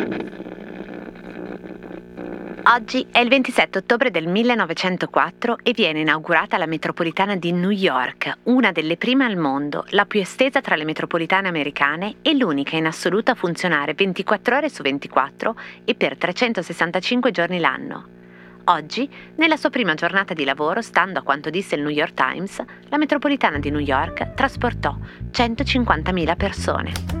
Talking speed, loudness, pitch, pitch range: 145 wpm, -20 LUFS, 175 Hz, 145-230 Hz